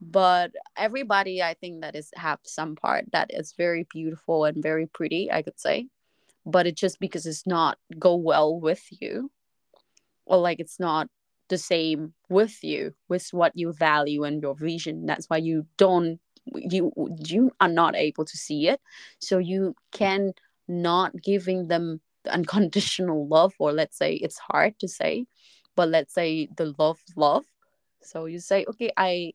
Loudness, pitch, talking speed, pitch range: -25 LUFS, 175 Hz, 170 wpm, 160-190 Hz